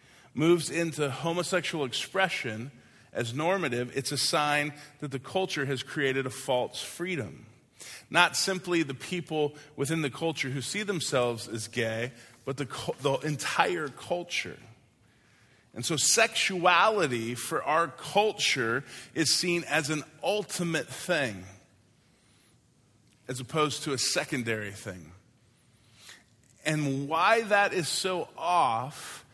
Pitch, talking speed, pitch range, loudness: 140 Hz, 120 wpm, 120-165 Hz, -28 LUFS